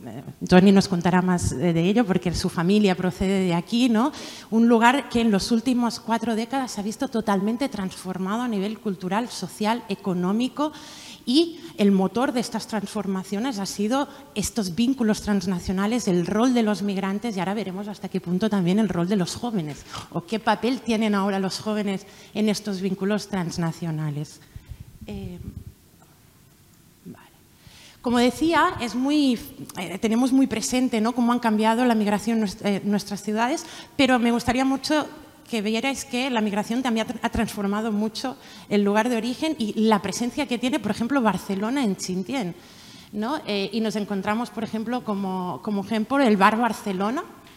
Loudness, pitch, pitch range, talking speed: -24 LUFS, 215 Hz, 195-240 Hz, 160 wpm